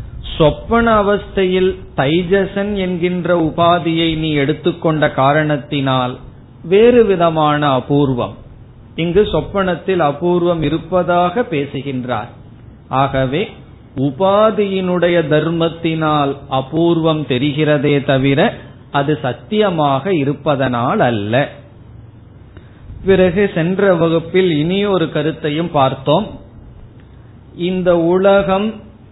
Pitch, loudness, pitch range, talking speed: 150 Hz, -15 LUFS, 130-180 Hz, 70 wpm